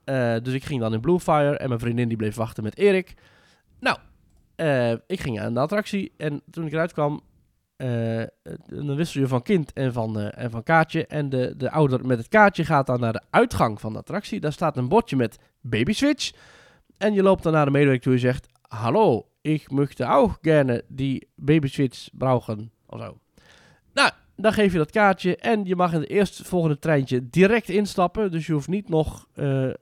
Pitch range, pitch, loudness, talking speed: 125-175 Hz, 145 Hz, -23 LUFS, 205 wpm